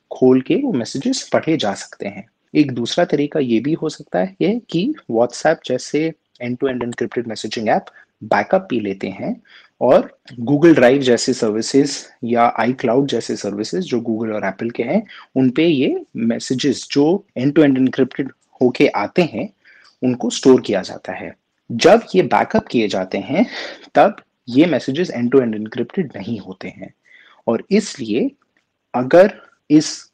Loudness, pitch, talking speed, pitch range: -17 LUFS, 130 Hz, 160 wpm, 120-160 Hz